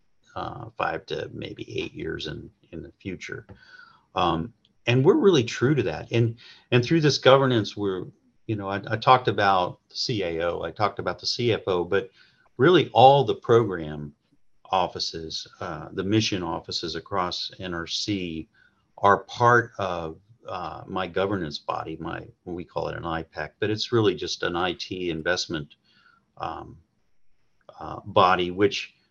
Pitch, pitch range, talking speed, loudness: 105 Hz, 90-120 Hz, 150 wpm, -24 LUFS